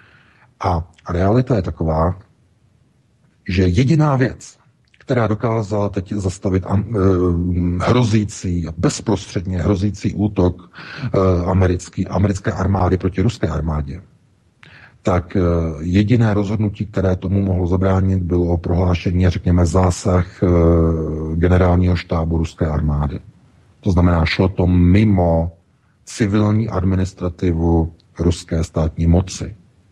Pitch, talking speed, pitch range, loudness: 95 Hz, 105 wpm, 85-100 Hz, -18 LUFS